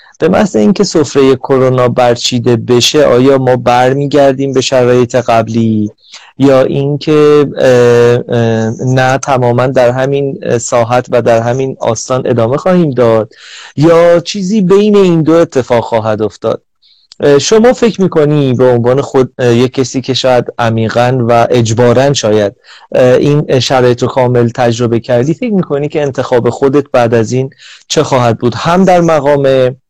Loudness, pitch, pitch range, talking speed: -9 LUFS, 130 Hz, 120-145 Hz, 135 wpm